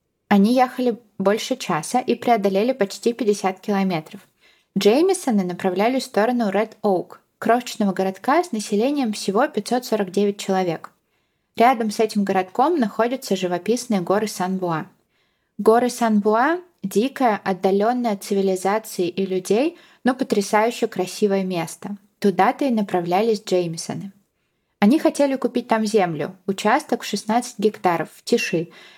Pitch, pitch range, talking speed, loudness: 210 Hz, 195-235 Hz, 120 wpm, -21 LUFS